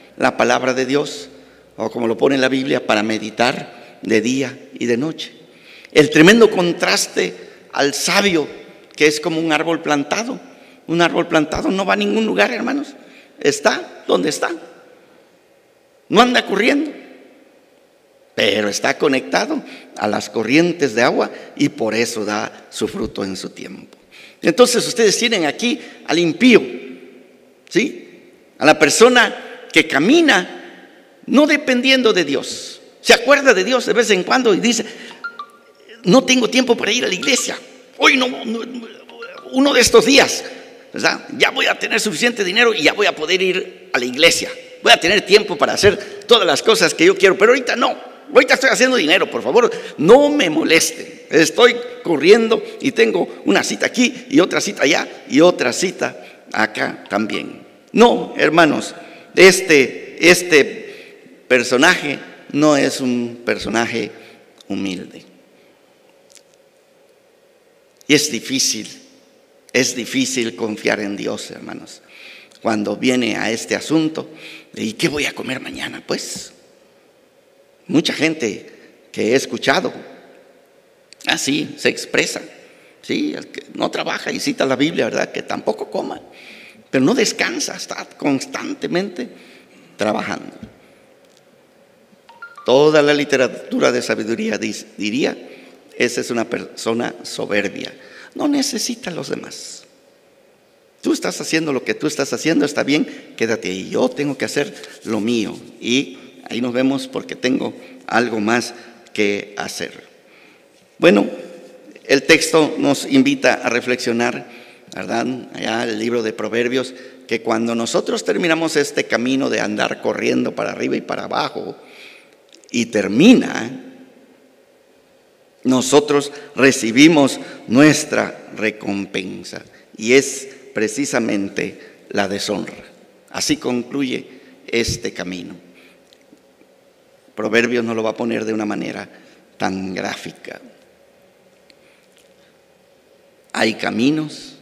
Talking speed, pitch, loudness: 130 wpm, 185 Hz, -16 LUFS